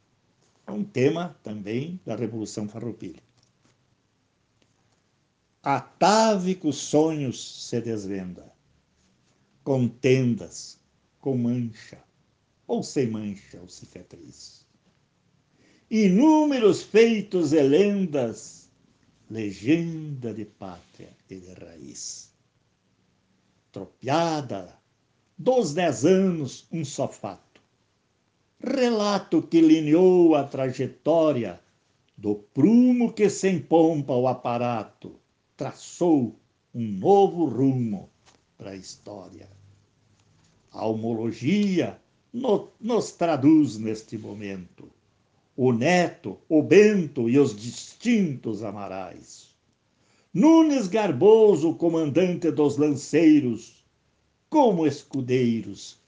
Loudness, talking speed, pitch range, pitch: -23 LUFS, 80 wpm, 110-175 Hz, 135 Hz